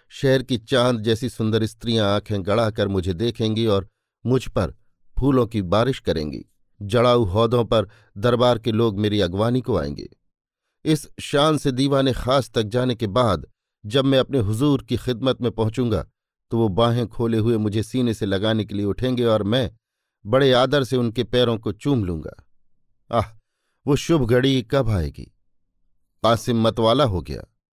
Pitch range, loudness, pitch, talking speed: 105-125 Hz, -21 LUFS, 115 Hz, 165 wpm